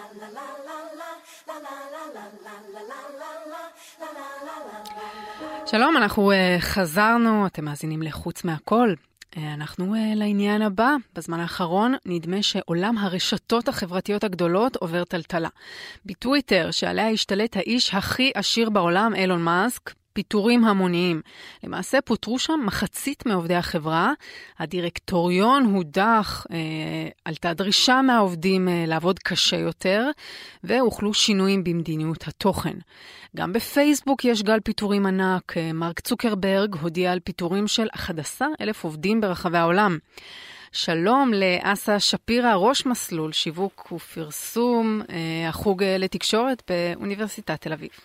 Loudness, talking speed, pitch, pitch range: -23 LUFS, 100 wpm, 205 Hz, 175-235 Hz